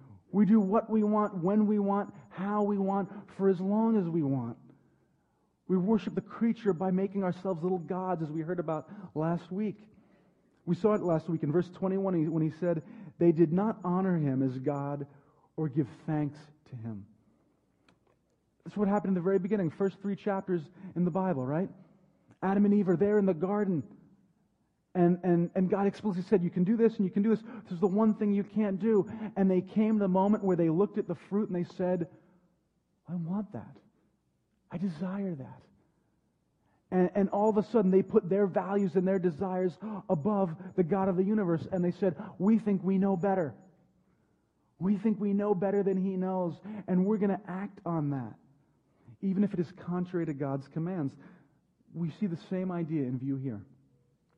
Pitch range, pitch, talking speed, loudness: 170-205 Hz, 190 Hz, 200 wpm, -30 LUFS